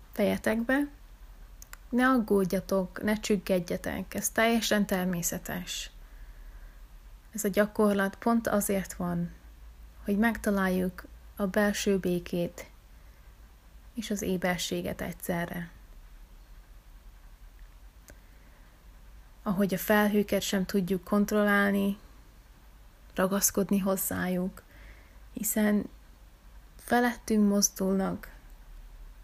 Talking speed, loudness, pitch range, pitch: 70 wpm, -29 LUFS, 180-210 Hz, 200 Hz